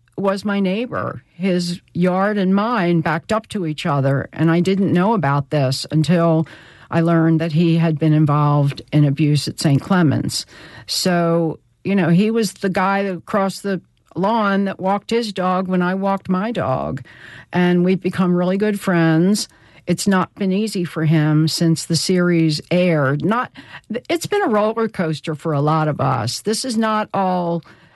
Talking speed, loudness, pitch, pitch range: 175 wpm, -18 LUFS, 175 Hz, 160-195 Hz